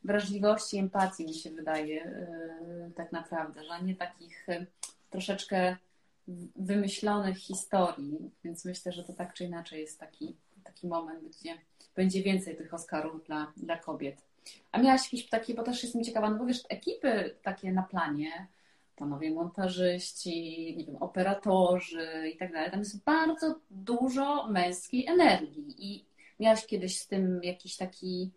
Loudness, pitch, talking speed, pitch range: -32 LUFS, 185 Hz, 145 wpm, 170-205 Hz